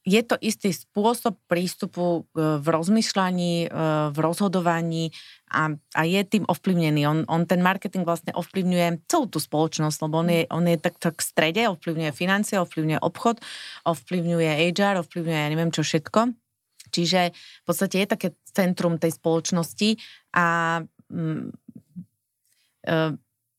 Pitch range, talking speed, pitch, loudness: 160-190 Hz, 135 wpm, 170 Hz, -24 LUFS